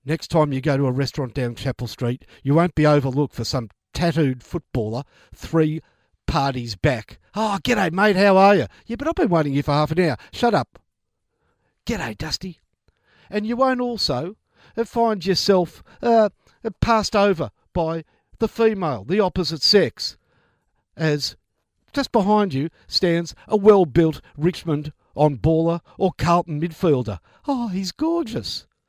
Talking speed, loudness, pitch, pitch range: 150 wpm, -21 LUFS, 165 Hz, 140-205 Hz